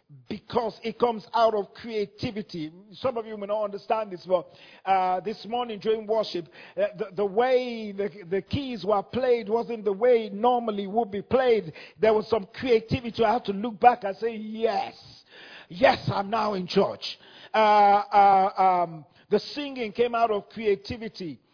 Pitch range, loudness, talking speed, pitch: 200-230 Hz, -25 LUFS, 175 wpm, 215 Hz